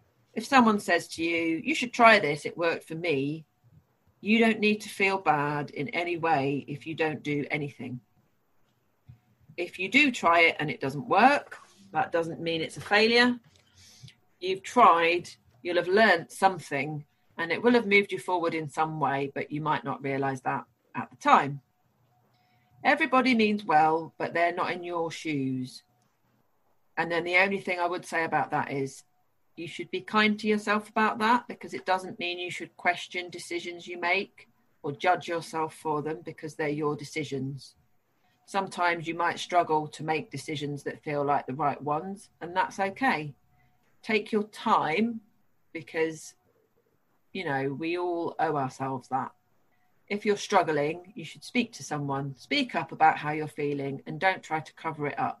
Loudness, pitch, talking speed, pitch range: -27 LUFS, 165 Hz, 175 wpm, 145-190 Hz